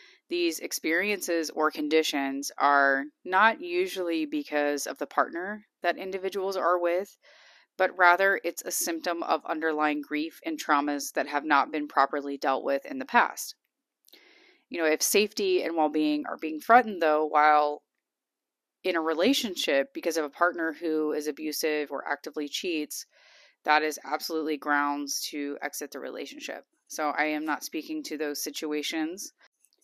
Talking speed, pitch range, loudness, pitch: 155 wpm, 150-190 Hz, -27 LUFS, 160 Hz